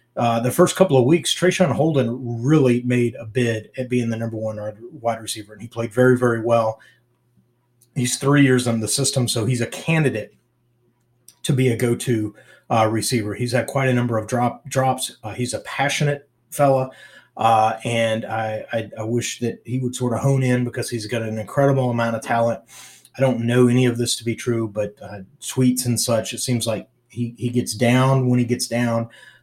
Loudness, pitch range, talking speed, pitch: -20 LUFS, 115-130 Hz, 205 wpm, 120 Hz